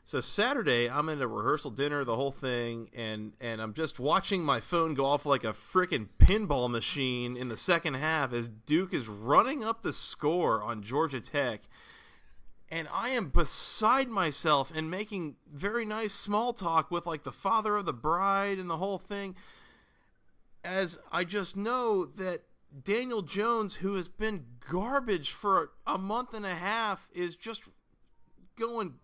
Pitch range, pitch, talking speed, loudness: 135-200 Hz, 175 Hz, 165 wpm, -31 LUFS